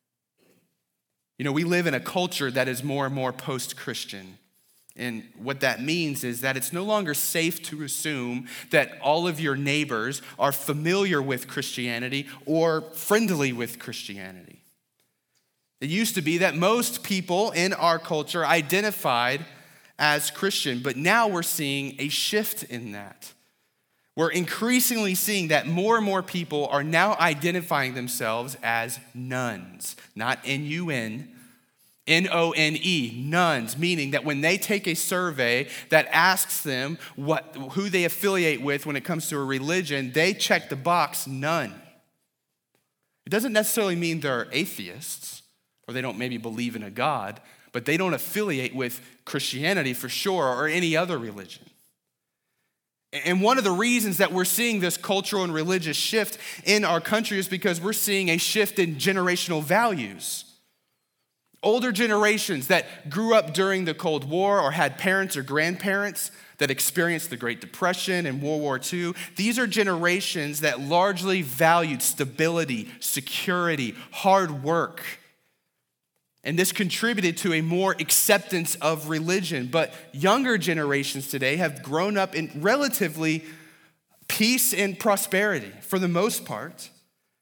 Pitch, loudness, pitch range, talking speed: 165 Hz, -24 LUFS, 140-190 Hz, 150 wpm